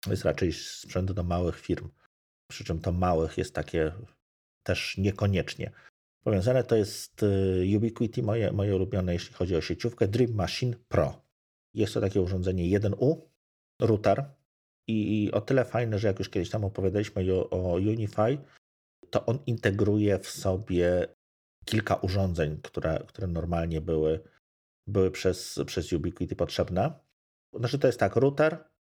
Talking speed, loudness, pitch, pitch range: 140 wpm, -29 LUFS, 95 Hz, 90-110 Hz